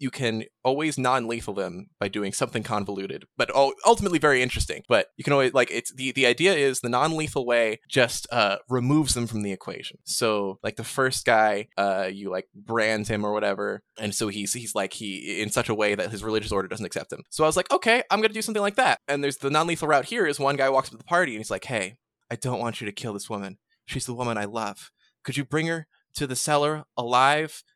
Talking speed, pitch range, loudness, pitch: 250 wpm, 105-140 Hz, -25 LUFS, 120 Hz